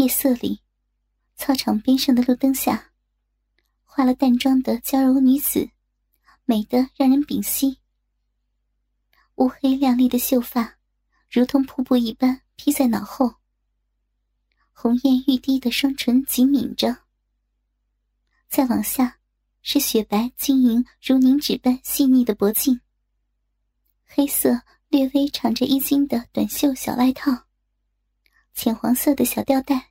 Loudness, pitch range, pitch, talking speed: -20 LUFS, 245-275 Hz, 260 Hz, 185 characters per minute